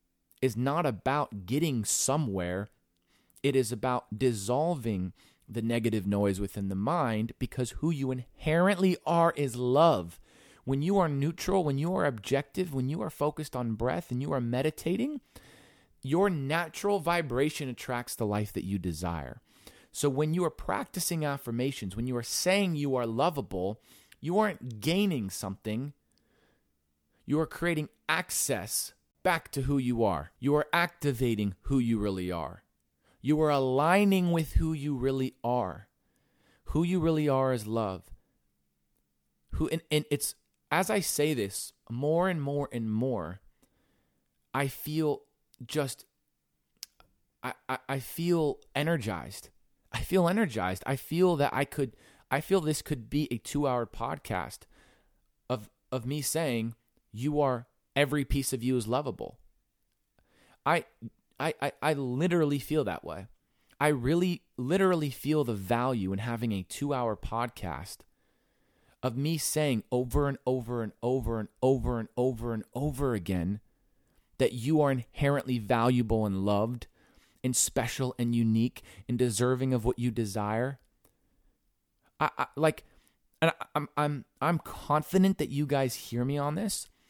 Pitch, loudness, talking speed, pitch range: 130 Hz, -30 LUFS, 145 wpm, 110-150 Hz